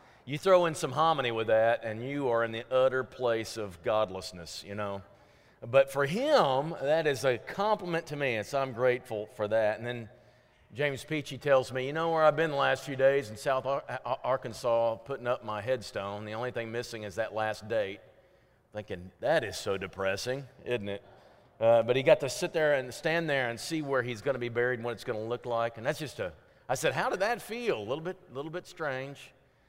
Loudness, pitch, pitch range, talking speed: -30 LUFS, 125 Hz, 110-140 Hz, 230 wpm